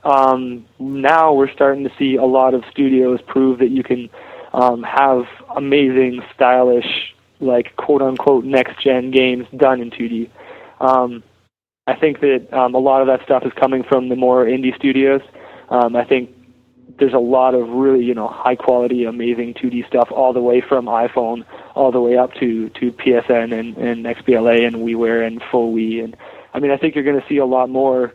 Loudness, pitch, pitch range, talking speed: -16 LUFS, 125 Hz, 120-135 Hz, 190 wpm